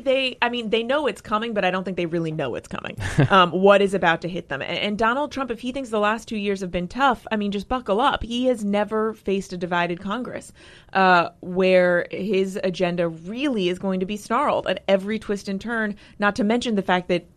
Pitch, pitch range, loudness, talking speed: 205 Hz, 185-230 Hz, -22 LUFS, 240 wpm